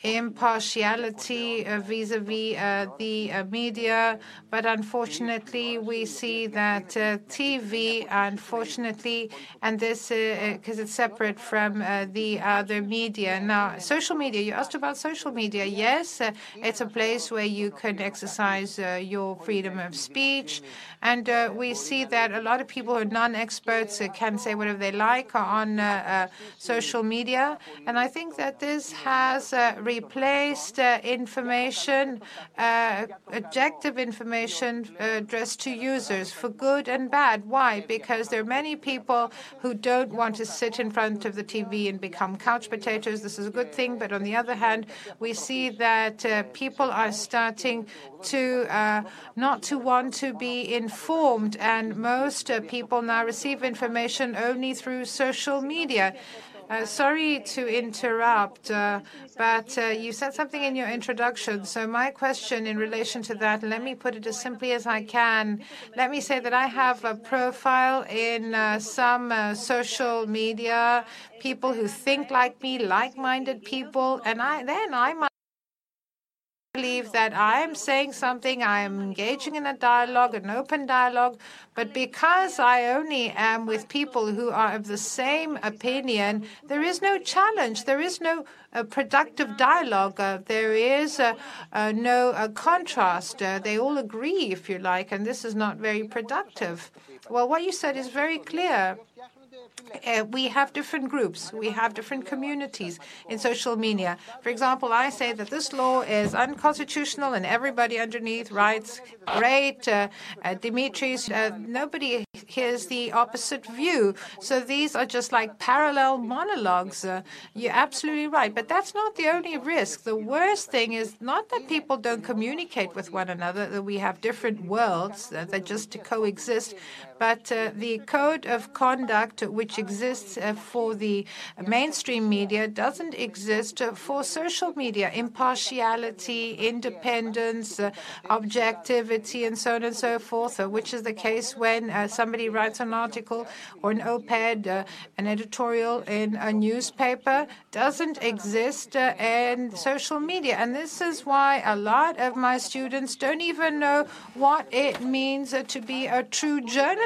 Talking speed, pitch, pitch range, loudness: 160 wpm, 235 Hz, 220-260 Hz, -26 LUFS